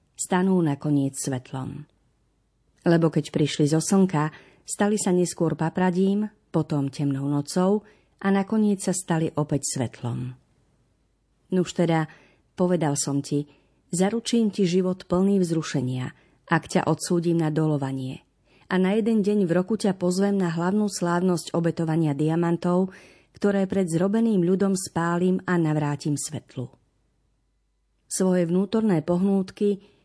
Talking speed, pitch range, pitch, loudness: 120 wpm, 150-190 Hz, 170 Hz, -24 LUFS